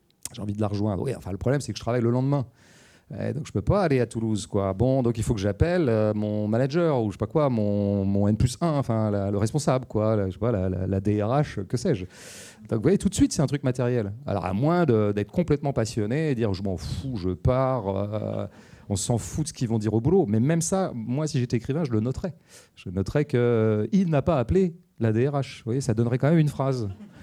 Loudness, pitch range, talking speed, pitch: -25 LUFS, 105-140 Hz, 260 wpm, 120 Hz